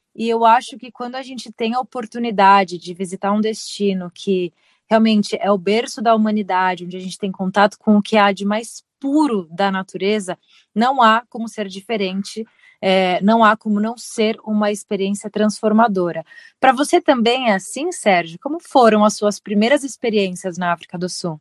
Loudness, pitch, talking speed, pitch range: -18 LUFS, 210 Hz, 180 wpm, 195-230 Hz